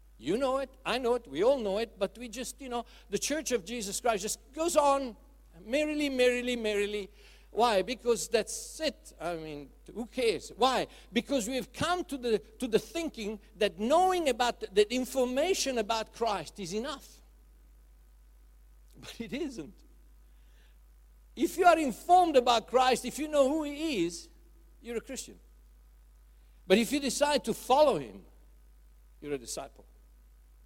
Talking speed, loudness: 155 wpm, -30 LUFS